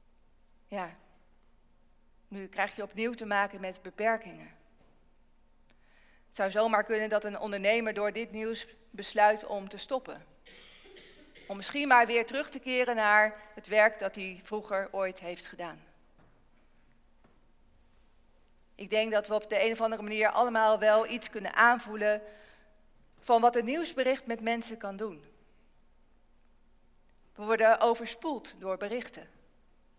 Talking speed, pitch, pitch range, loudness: 135 wpm, 215 Hz, 205-230 Hz, -29 LUFS